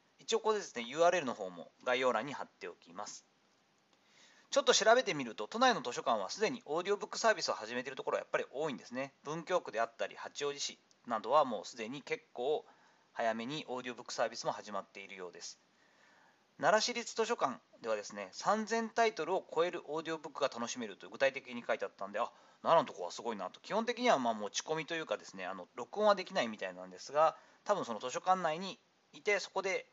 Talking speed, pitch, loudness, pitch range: 465 characters per minute, 175 Hz, -35 LUFS, 135-220 Hz